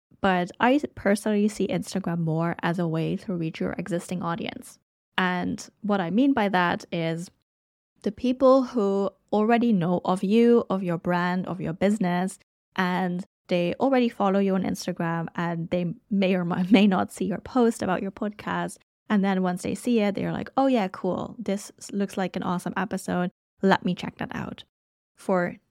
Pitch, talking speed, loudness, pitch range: 190 Hz, 175 wpm, -25 LUFS, 180-215 Hz